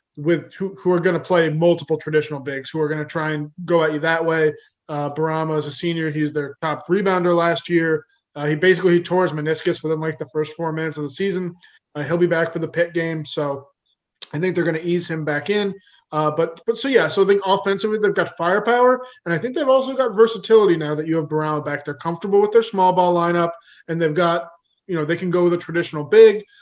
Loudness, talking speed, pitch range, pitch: -20 LUFS, 250 wpm, 155-185 Hz, 170 Hz